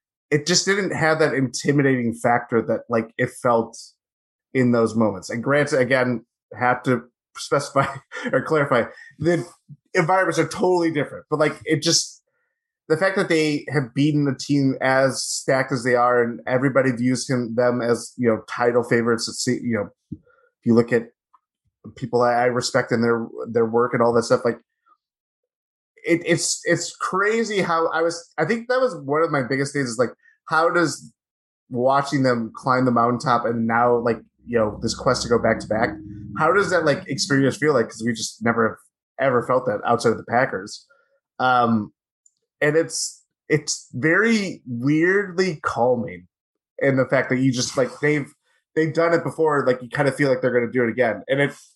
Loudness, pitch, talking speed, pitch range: -21 LUFS, 135 Hz, 190 wpm, 120-165 Hz